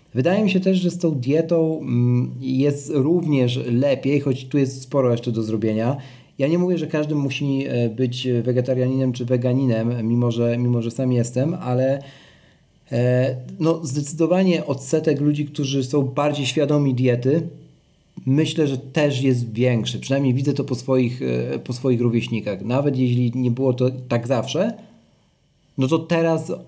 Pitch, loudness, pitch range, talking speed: 135 Hz, -21 LUFS, 125-150 Hz, 150 wpm